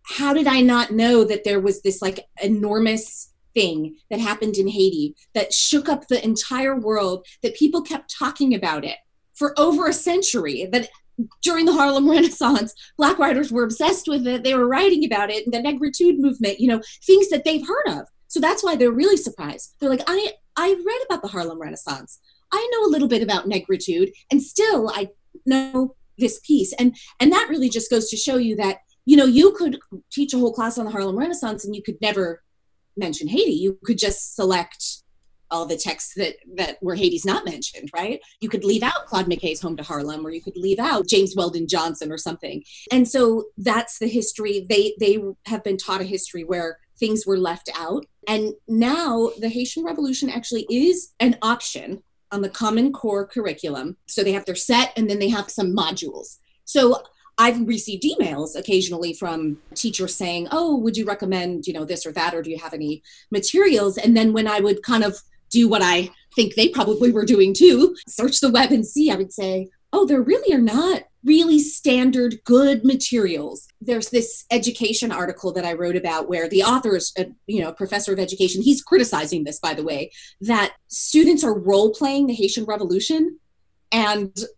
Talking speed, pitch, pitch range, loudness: 200 wpm, 225 Hz, 195-275 Hz, -20 LUFS